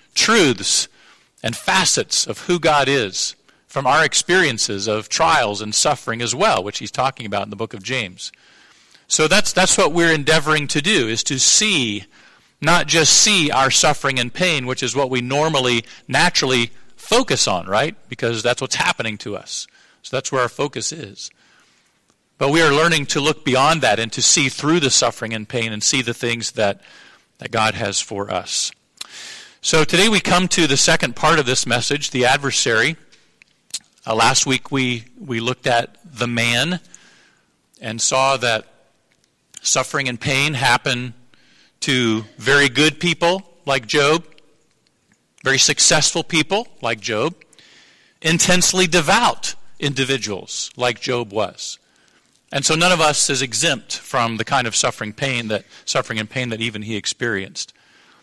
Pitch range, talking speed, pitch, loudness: 120-155 Hz, 160 wpm, 135 Hz, -17 LUFS